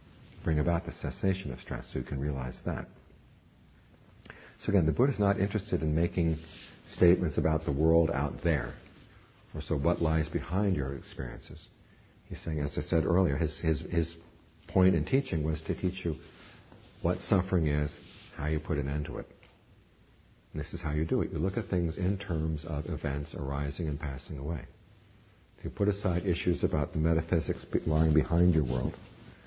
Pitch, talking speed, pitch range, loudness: 85 Hz, 185 wpm, 75-95 Hz, -31 LUFS